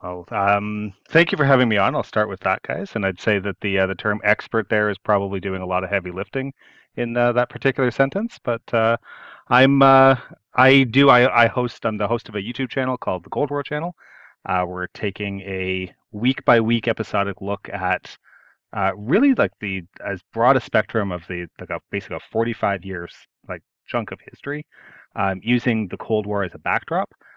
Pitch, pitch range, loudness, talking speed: 110 Hz, 100-125 Hz, -21 LUFS, 210 wpm